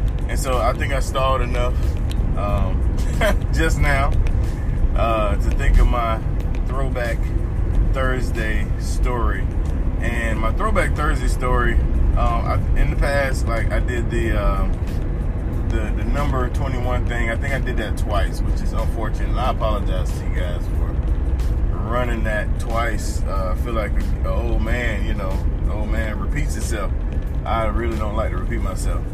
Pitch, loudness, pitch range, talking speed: 90 Hz, -22 LUFS, 75-105 Hz, 160 wpm